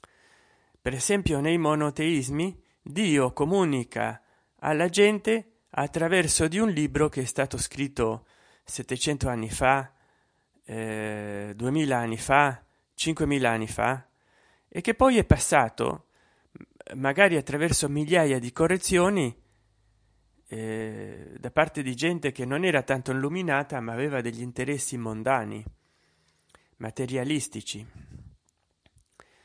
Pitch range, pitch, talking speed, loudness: 120-160 Hz, 135 Hz, 105 wpm, -26 LUFS